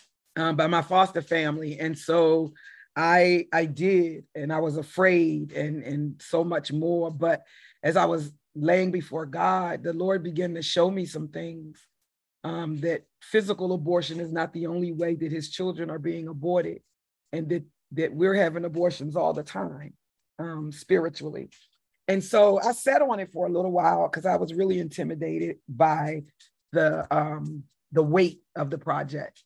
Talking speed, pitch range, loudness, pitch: 170 wpm, 155-175 Hz, -26 LUFS, 165 Hz